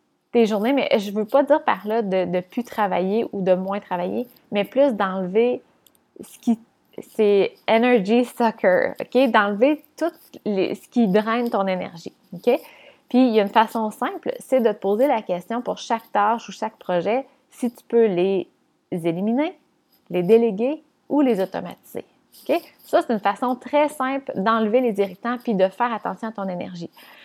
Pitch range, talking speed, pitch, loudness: 200-255 Hz, 180 wpm, 230 Hz, -22 LUFS